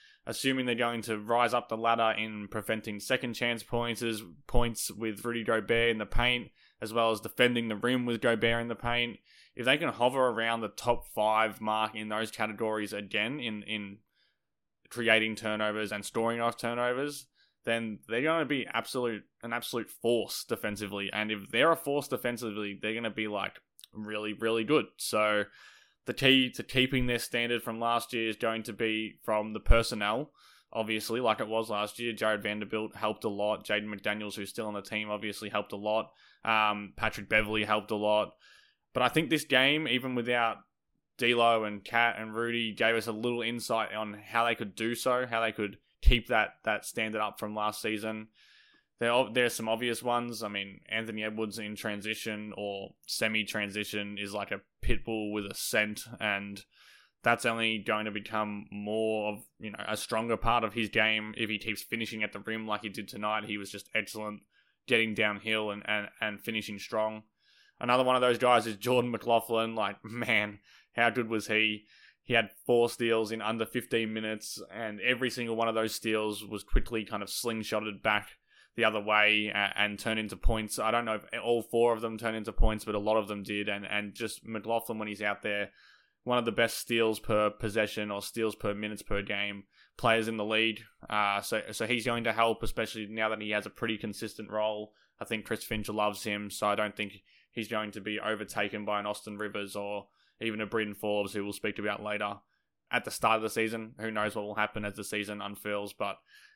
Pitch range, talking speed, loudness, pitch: 105-115 Hz, 200 wpm, -31 LUFS, 110 Hz